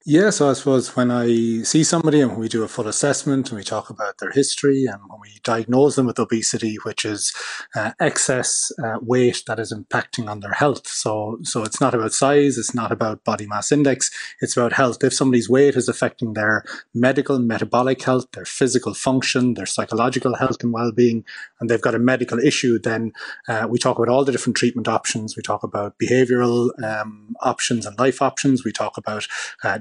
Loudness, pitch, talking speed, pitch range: -20 LUFS, 120 Hz, 200 wpm, 110-130 Hz